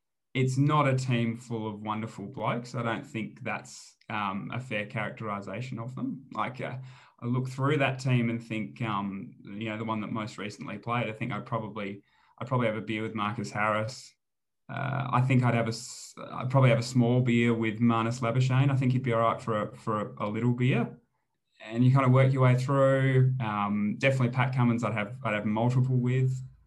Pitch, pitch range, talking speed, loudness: 120 Hz, 110-130 Hz, 210 wpm, -28 LUFS